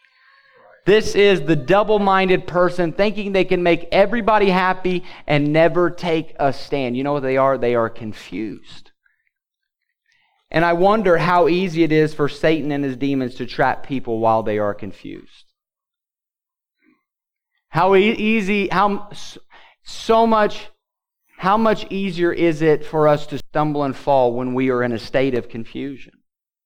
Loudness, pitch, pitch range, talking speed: -18 LUFS, 170 Hz, 140-205 Hz, 150 wpm